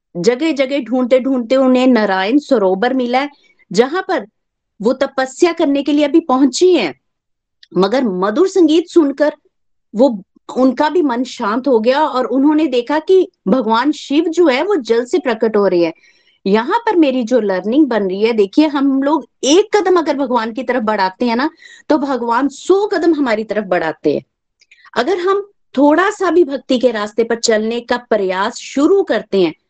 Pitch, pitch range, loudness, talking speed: 265 Hz, 230-315 Hz, -15 LUFS, 180 wpm